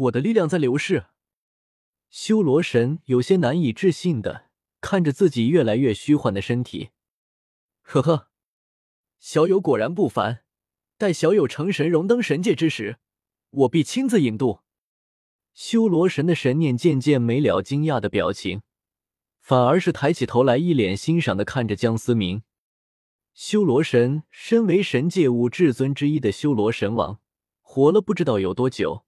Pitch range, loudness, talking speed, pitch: 110-165 Hz, -21 LUFS, 230 characters per minute, 130 Hz